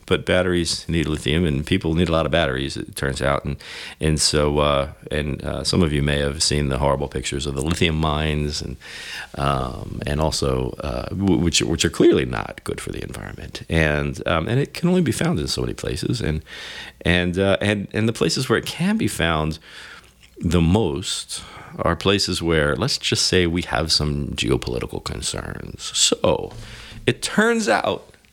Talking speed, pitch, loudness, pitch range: 185 wpm, 80 Hz, -21 LUFS, 70-90 Hz